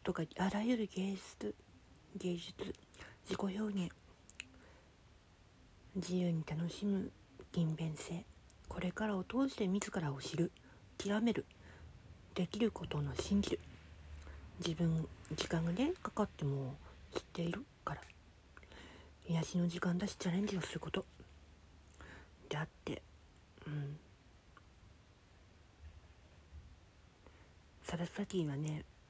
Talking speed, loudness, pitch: 190 characters per minute, -40 LUFS, 150 Hz